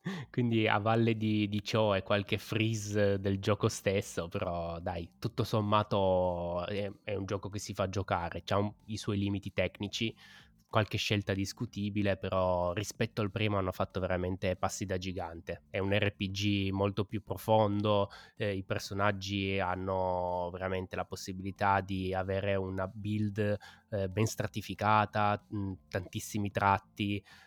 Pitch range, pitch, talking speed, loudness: 95-105 Hz, 100 Hz, 140 wpm, -33 LUFS